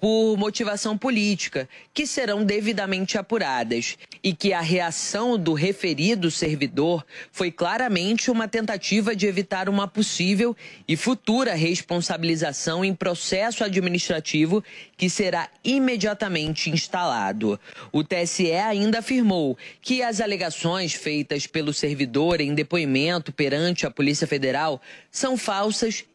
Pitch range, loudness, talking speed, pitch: 160-215 Hz, -24 LUFS, 115 wpm, 185 Hz